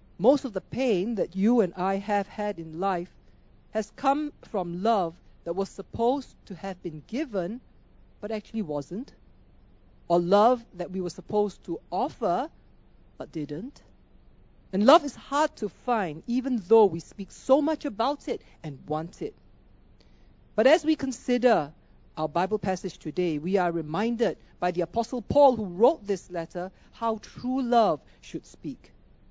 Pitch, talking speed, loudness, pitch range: 205 Hz, 160 wpm, -27 LUFS, 175-245 Hz